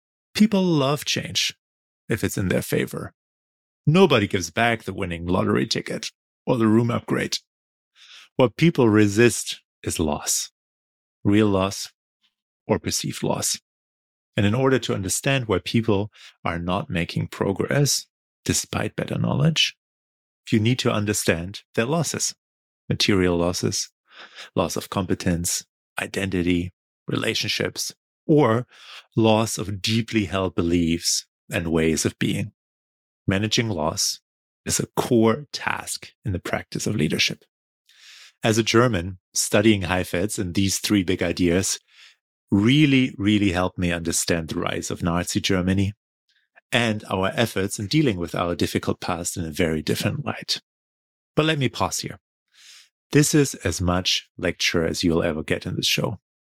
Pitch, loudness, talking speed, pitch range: 100 Hz, -23 LUFS, 135 wpm, 85-115 Hz